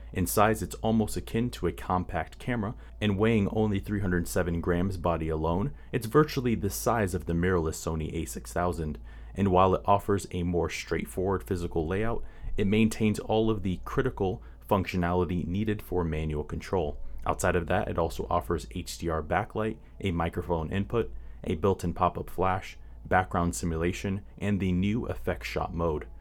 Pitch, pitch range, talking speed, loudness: 90 Hz, 85-105 Hz, 160 wpm, -29 LUFS